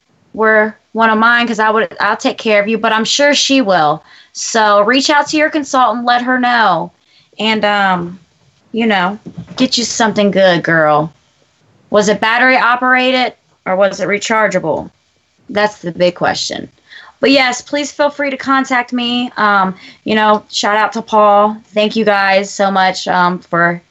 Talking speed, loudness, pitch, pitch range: 175 wpm, -12 LUFS, 215 Hz, 190-245 Hz